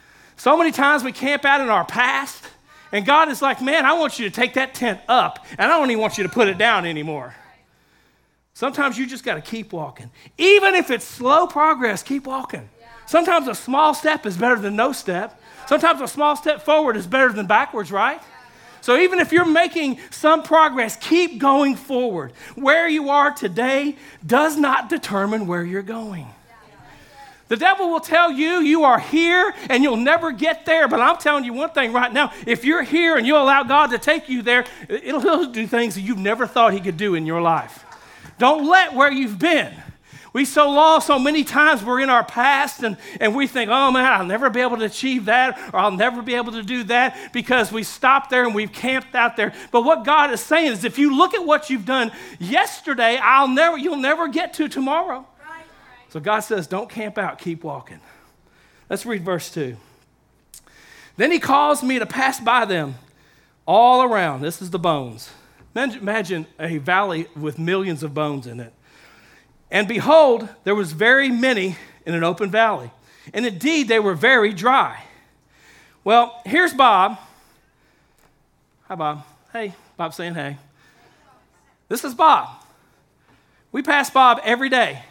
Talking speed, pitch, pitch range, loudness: 185 wpm, 250 Hz, 210-295 Hz, -18 LUFS